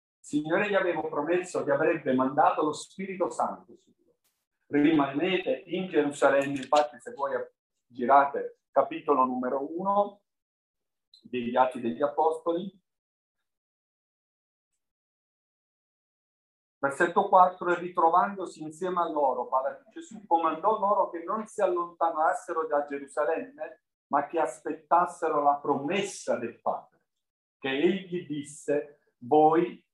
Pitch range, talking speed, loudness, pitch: 145-180 Hz, 105 wpm, -27 LUFS, 160 Hz